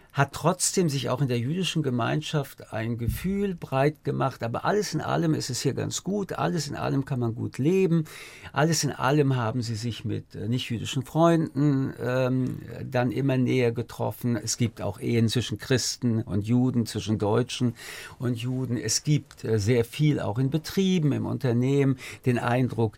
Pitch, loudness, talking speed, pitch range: 130 Hz, -26 LUFS, 170 wpm, 115-150 Hz